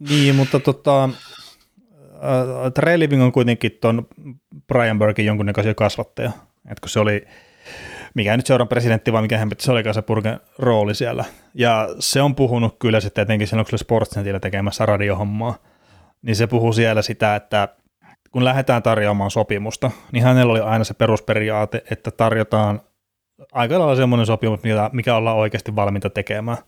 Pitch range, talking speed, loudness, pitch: 105-125 Hz, 155 wpm, -19 LUFS, 110 Hz